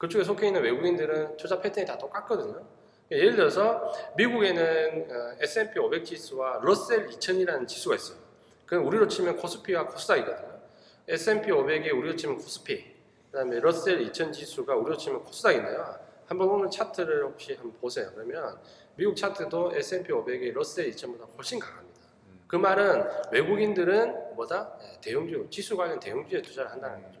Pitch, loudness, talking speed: 370 Hz, -28 LUFS, 355 characters per minute